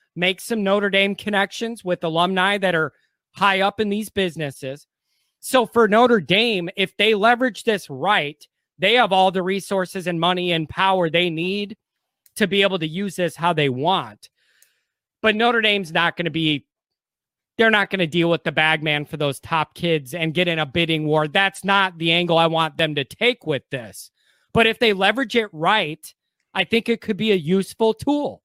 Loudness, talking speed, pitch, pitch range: -20 LUFS, 195 wpm, 190 Hz, 165-210 Hz